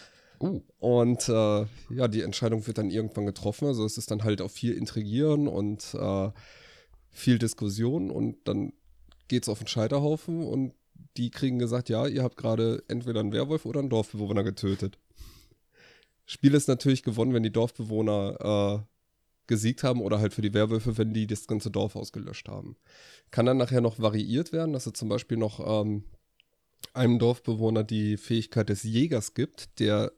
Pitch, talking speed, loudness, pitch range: 110 Hz, 170 wpm, -28 LUFS, 105-125 Hz